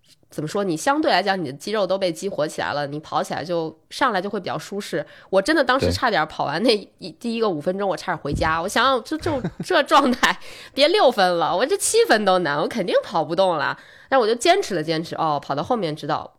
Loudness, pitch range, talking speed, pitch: -21 LUFS, 165-265 Hz, 340 characters per minute, 190 Hz